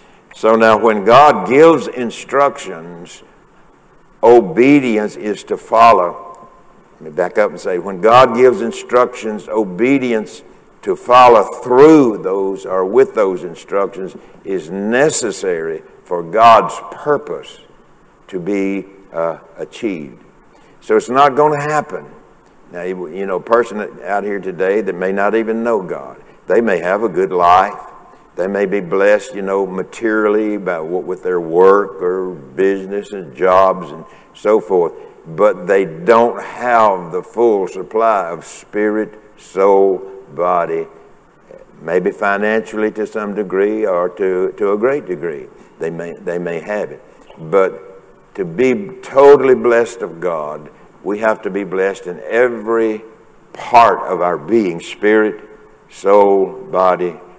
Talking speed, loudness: 140 wpm, -14 LUFS